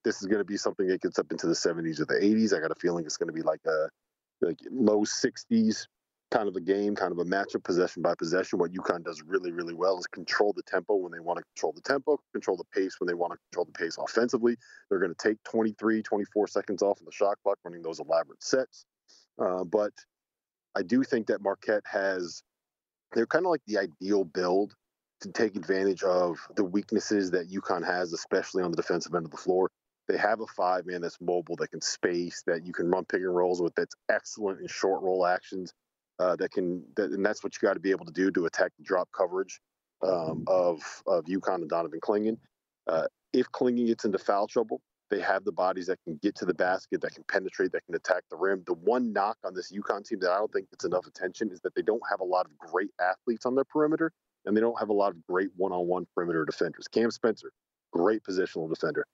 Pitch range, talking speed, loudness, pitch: 90-155 Hz, 240 wpm, -30 LUFS, 105 Hz